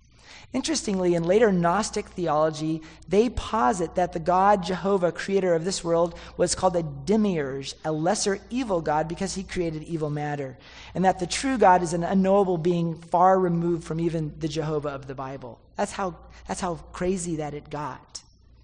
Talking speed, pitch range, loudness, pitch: 175 wpm, 155-190 Hz, -25 LUFS, 175 Hz